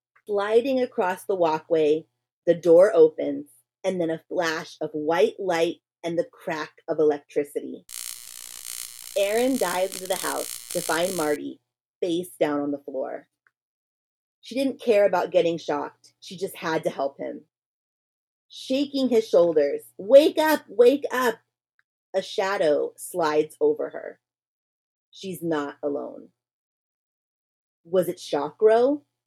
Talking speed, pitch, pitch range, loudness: 125 wpm, 170 Hz, 145-215 Hz, -24 LUFS